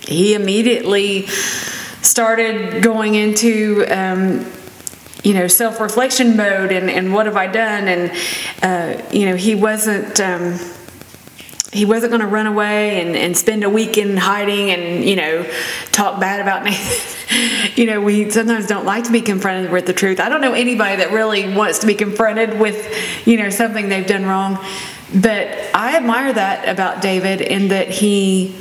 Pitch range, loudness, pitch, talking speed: 190-220 Hz, -15 LUFS, 205 Hz, 170 wpm